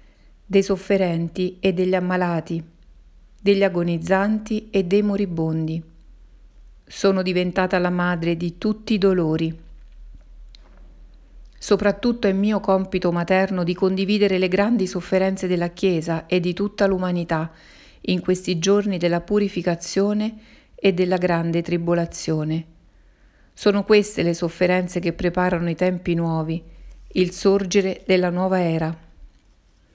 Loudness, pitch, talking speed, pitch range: -21 LUFS, 180 Hz, 115 wpm, 170-195 Hz